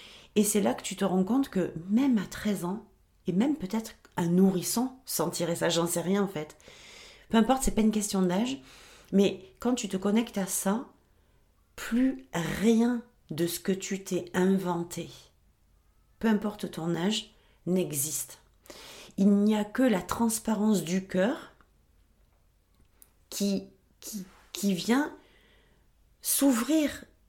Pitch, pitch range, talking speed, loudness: 195 Hz, 170-220 Hz, 145 wpm, -28 LUFS